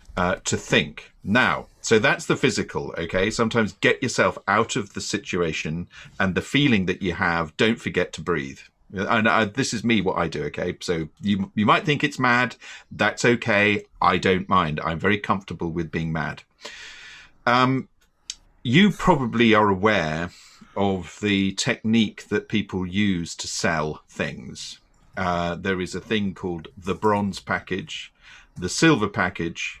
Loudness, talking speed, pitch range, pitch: -23 LUFS, 160 wpm, 90-115 Hz, 100 Hz